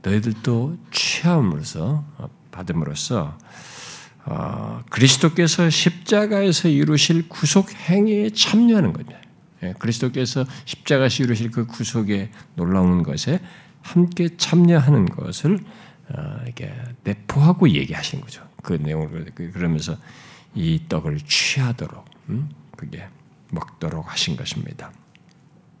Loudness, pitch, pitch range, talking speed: -20 LUFS, 150 Hz, 120-175 Hz, 255 characters per minute